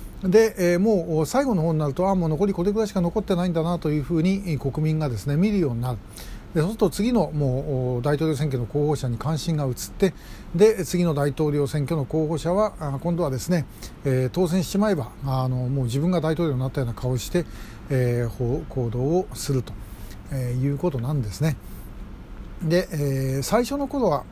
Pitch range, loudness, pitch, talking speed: 130-175 Hz, -24 LUFS, 150 Hz, 350 characters per minute